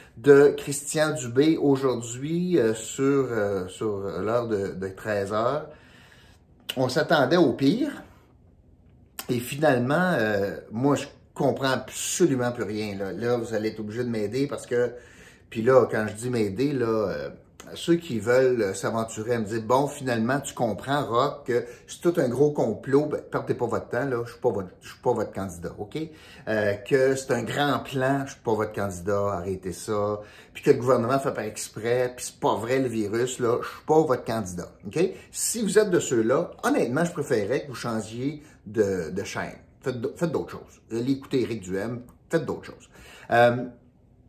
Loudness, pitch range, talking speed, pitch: -25 LUFS, 110-135 Hz, 185 wpm, 120 Hz